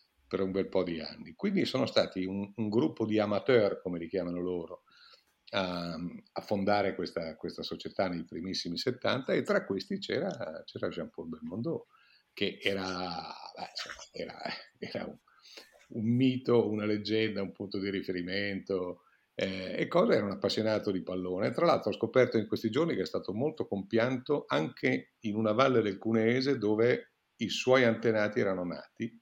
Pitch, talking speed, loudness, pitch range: 100 Hz, 160 wpm, -32 LUFS, 95-115 Hz